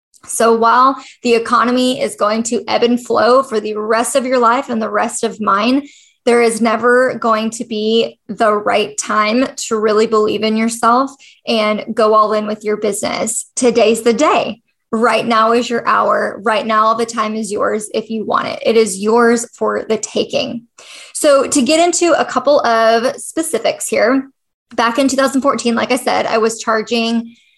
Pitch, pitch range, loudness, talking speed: 230 Hz, 220-255 Hz, -14 LUFS, 185 wpm